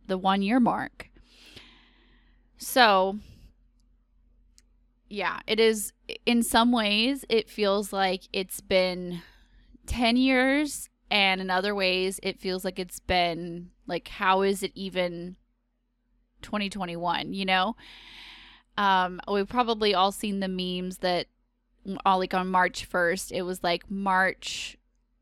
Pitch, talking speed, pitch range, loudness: 190 Hz, 130 wpm, 180-210 Hz, -26 LUFS